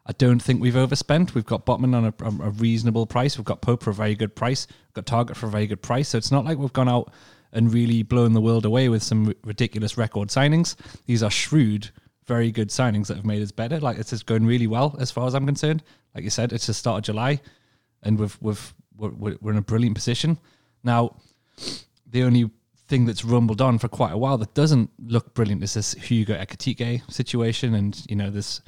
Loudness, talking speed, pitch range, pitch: -23 LUFS, 230 wpm, 110-130 Hz, 115 Hz